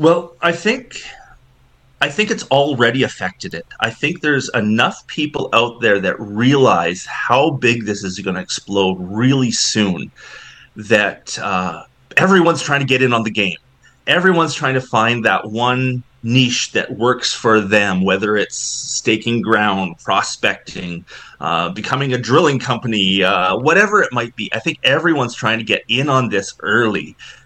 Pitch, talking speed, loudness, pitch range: 120 Hz, 160 wpm, -16 LUFS, 105-135 Hz